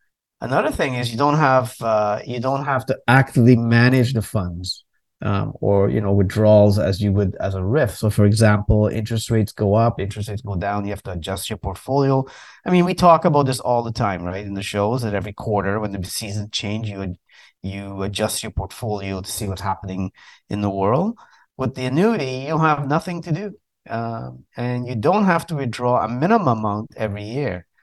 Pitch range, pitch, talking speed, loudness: 100-130 Hz, 110 Hz, 205 wpm, -20 LUFS